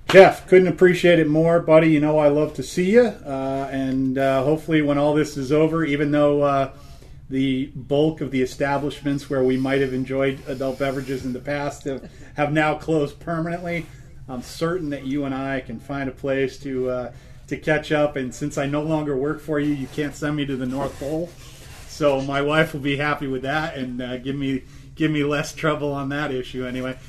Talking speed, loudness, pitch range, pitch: 215 wpm, -21 LUFS, 135-150 Hz, 140 Hz